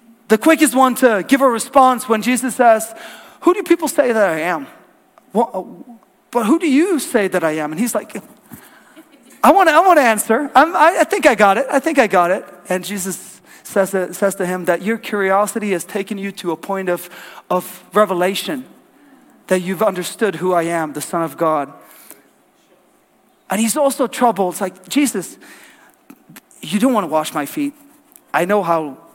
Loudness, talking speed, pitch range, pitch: -16 LUFS, 190 wpm, 185-275 Hz, 220 Hz